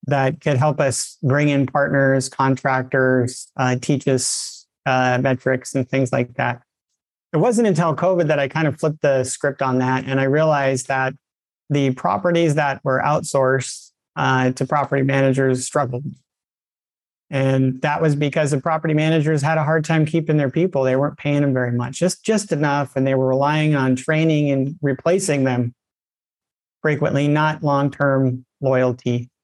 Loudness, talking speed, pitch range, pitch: -19 LUFS, 165 wpm, 130-150 Hz, 140 Hz